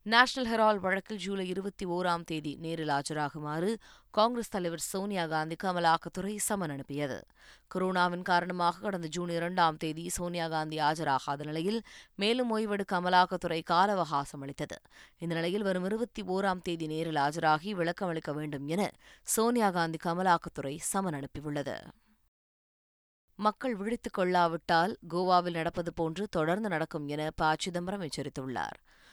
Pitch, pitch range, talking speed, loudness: 175 Hz, 155-195 Hz, 125 wpm, -31 LUFS